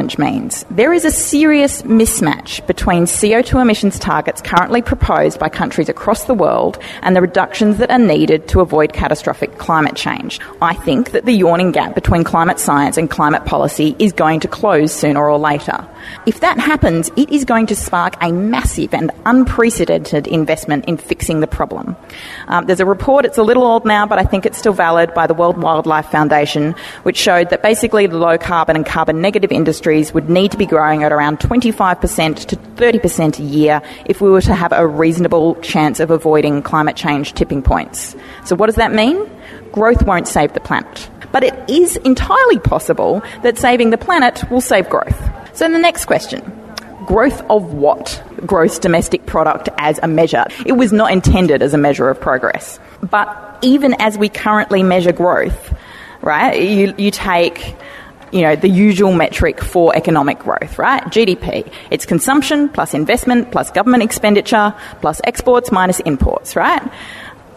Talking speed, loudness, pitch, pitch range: 175 wpm, -13 LUFS, 185 Hz, 160-230 Hz